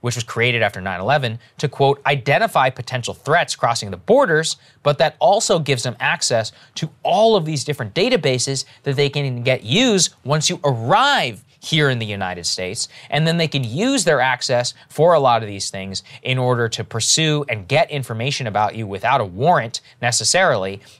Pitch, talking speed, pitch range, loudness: 130 Hz, 185 wpm, 115-145 Hz, -18 LUFS